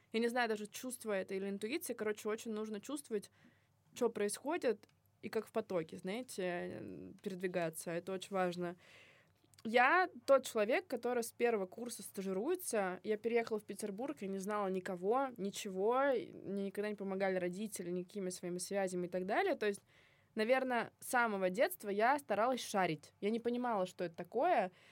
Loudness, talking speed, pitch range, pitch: -38 LUFS, 160 wpm, 190-235 Hz, 210 Hz